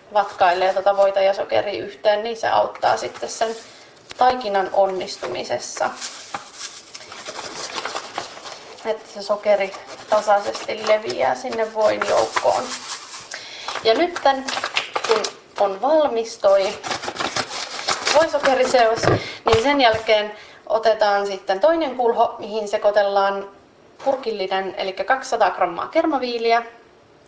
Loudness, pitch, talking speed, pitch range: -20 LUFS, 220 Hz, 90 wpm, 200-250 Hz